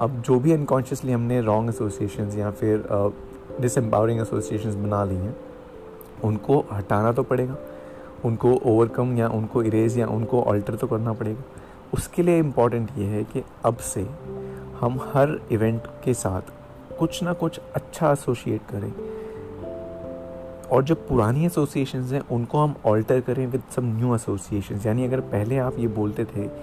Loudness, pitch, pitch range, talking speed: -24 LUFS, 115 Hz, 105-130 Hz, 155 wpm